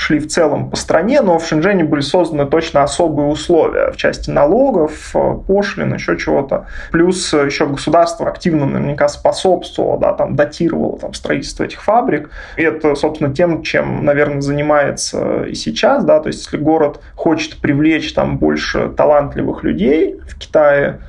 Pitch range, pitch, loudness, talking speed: 145-175 Hz, 155 Hz, -15 LUFS, 155 wpm